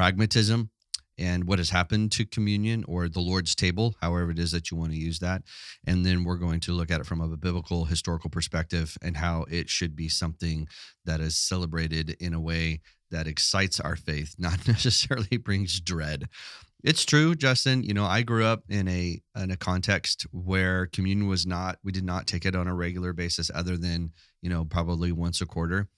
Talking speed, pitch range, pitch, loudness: 200 wpm, 85-100 Hz, 90 Hz, -27 LUFS